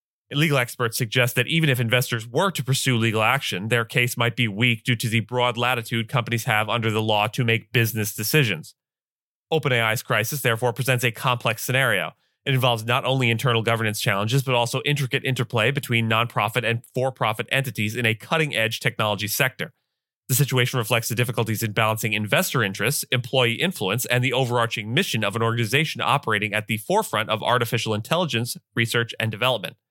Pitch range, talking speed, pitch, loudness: 115-130 Hz, 180 wpm, 120 Hz, -22 LUFS